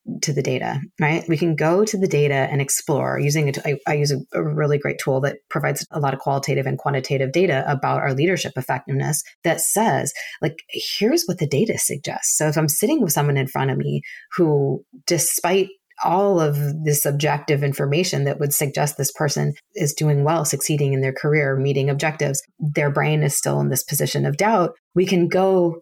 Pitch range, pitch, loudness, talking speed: 140-165 Hz, 145 Hz, -20 LUFS, 200 wpm